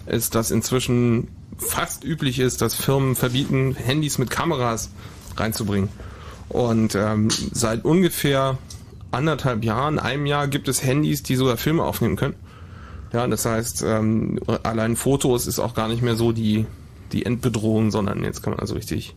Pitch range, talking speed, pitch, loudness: 110-130 Hz, 155 wpm, 115 Hz, -22 LUFS